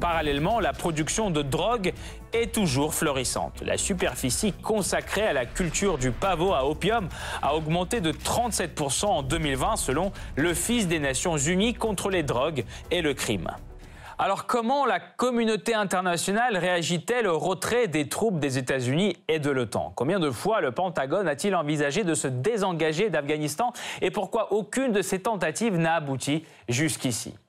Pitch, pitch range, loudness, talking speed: 175 Hz, 150-220 Hz, -26 LUFS, 155 wpm